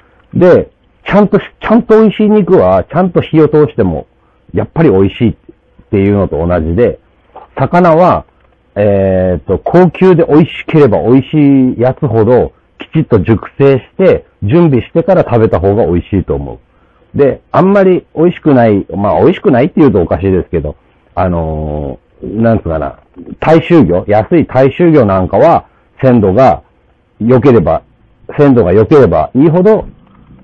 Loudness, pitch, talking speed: -9 LUFS, 120 Hz, 315 characters per minute